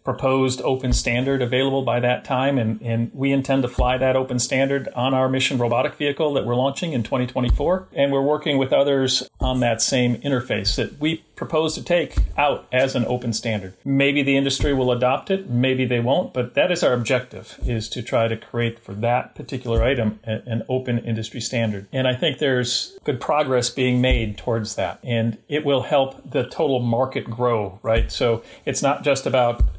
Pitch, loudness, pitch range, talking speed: 130 Hz, -21 LUFS, 120-135 Hz, 195 wpm